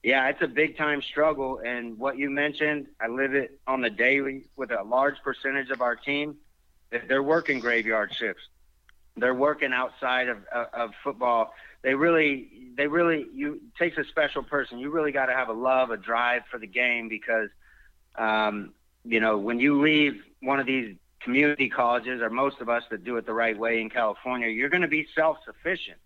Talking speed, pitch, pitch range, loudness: 195 wpm, 130 Hz, 120-145 Hz, -26 LUFS